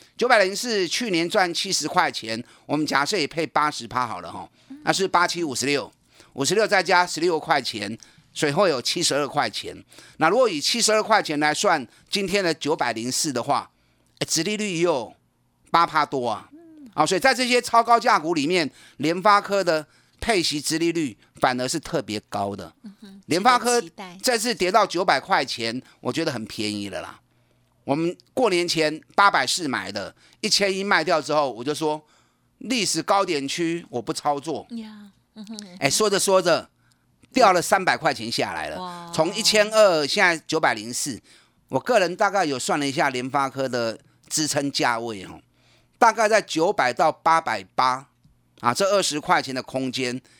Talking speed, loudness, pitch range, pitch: 255 characters per minute, -22 LUFS, 140-205 Hz, 165 Hz